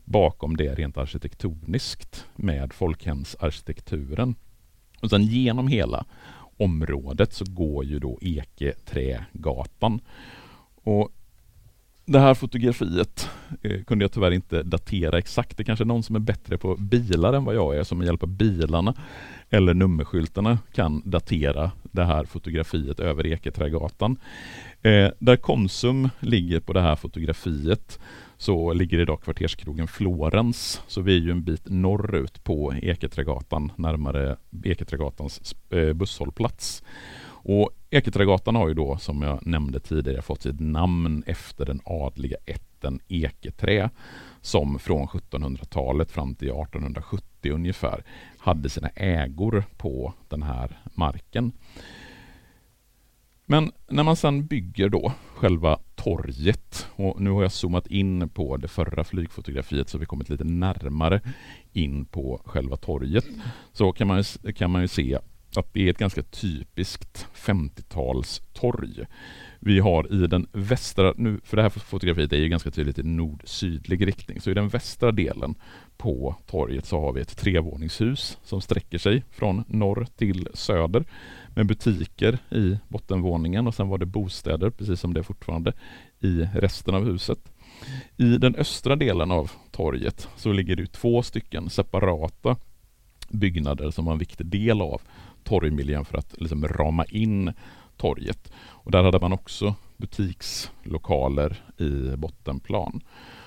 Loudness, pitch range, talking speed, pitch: -25 LUFS, 80-105 Hz, 140 wpm, 90 Hz